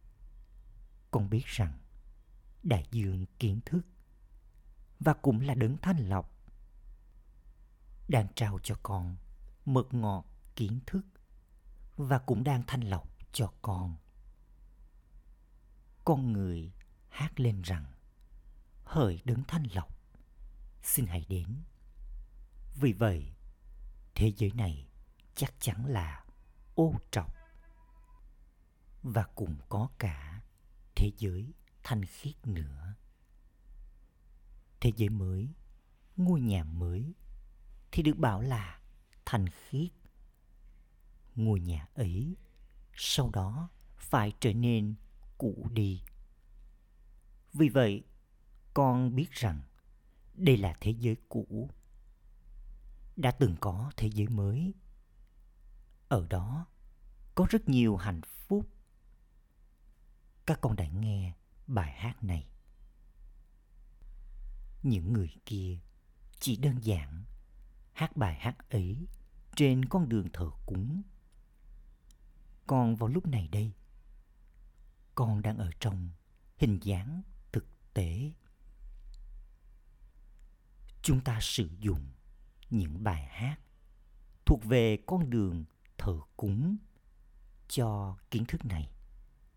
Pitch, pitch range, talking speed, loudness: 105 Hz, 90-120 Hz, 105 wpm, -33 LUFS